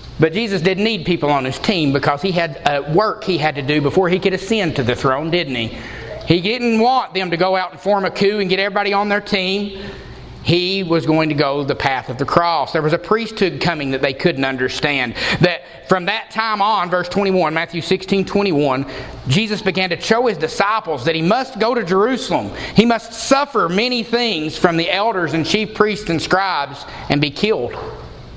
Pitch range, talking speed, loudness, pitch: 150-205 Hz, 210 wpm, -17 LUFS, 180 Hz